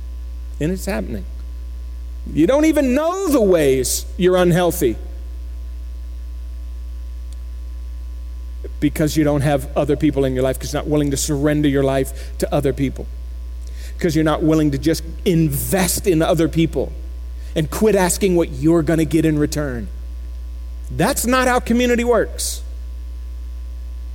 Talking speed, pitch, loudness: 135 wpm, 120 Hz, -18 LUFS